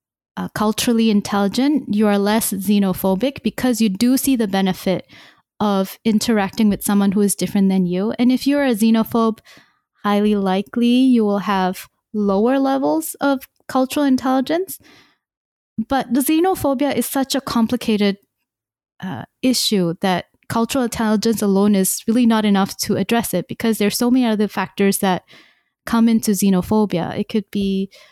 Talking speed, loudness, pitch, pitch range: 150 wpm, -18 LUFS, 215 Hz, 200-250 Hz